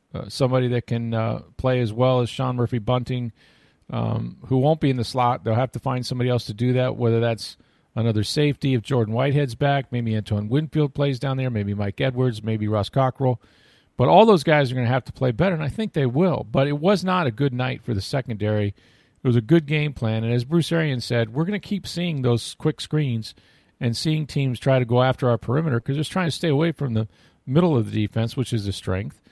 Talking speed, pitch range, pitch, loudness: 240 wpm, 115-145 Hz, 125 Hz, -22 LUFS